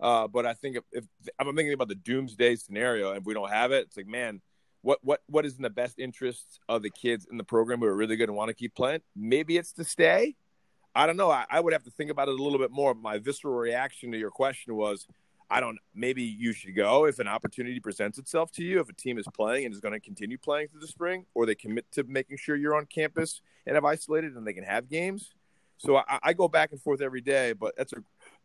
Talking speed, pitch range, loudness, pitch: 280 wpm, 120-155 Hz, -29 LUFS, 135 Hz